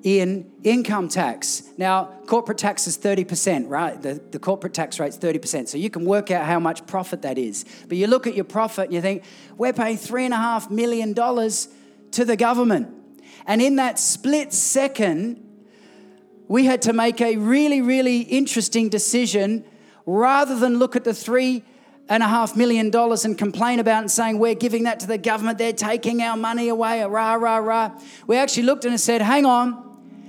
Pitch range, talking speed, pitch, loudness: 195-240 Hz, 200 wpm, 225 Hz, -21 LUFS